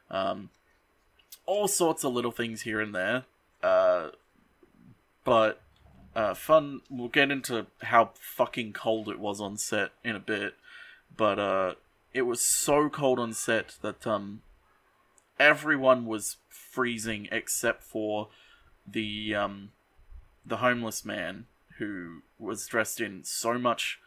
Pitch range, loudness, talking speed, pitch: 110-150 Hz, -28 LUFS, 130 wpm, 120 Hz